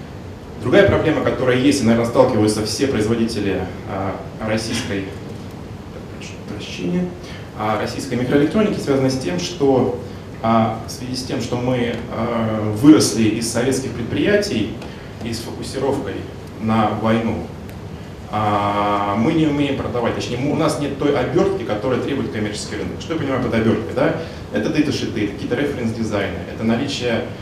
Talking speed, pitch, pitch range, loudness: 135 wpm, 110 Hz, 100-125 Hz, -19 LUFS